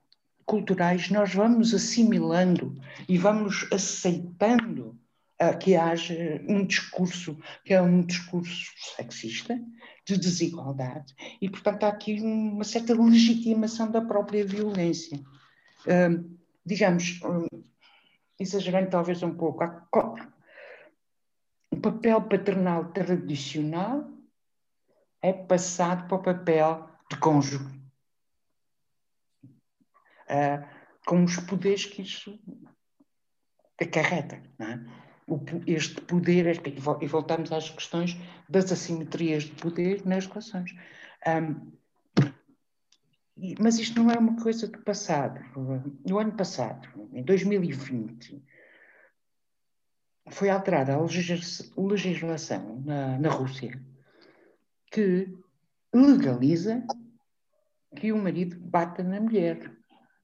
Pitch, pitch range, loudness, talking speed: 180 Hz, 160-205 Hz, -27 LUFS, 95 wpm